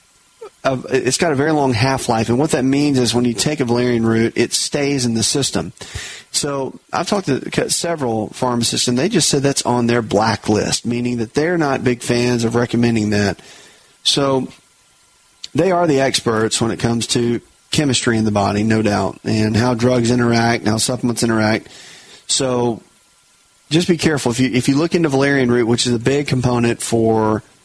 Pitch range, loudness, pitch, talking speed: 115-135 Hz, -16 LUFS, 120 Hz, 190 wpm